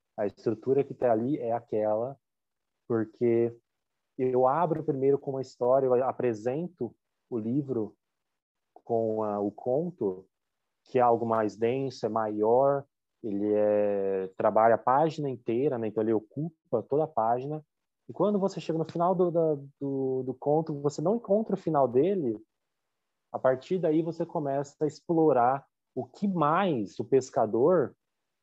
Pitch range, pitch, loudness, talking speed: 115-155 Hz, 135 Hz, -28 LUFS, 150 wpm